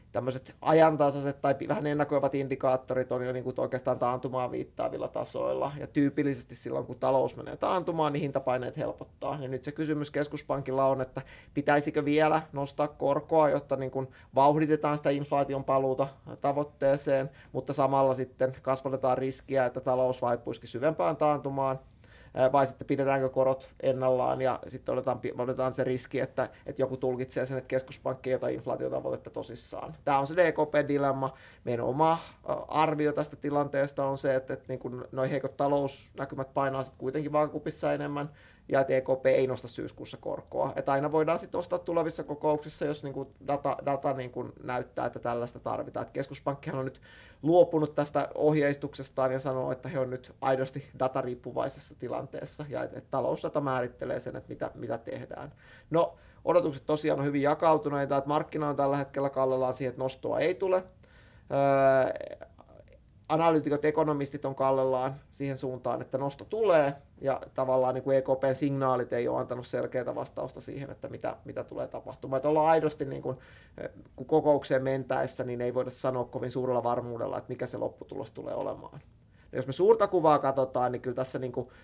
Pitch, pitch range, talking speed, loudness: 135 Hz, 130-145 Hz, 165 wpm, -30 LUFS